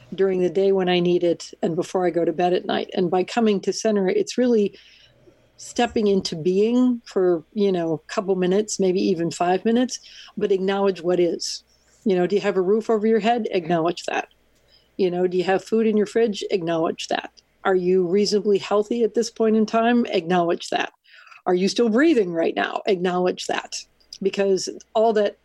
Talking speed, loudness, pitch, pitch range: 200 wpm, -22 LUFS, 195 Hz, 180-220 Hz